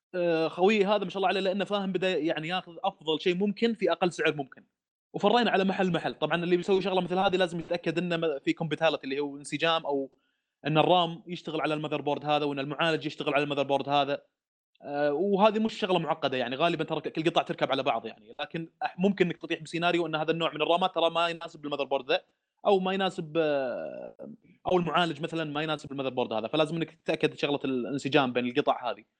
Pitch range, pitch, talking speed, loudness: 145-180 Hz, 165 Hz, 195 wpm, -28 LUFS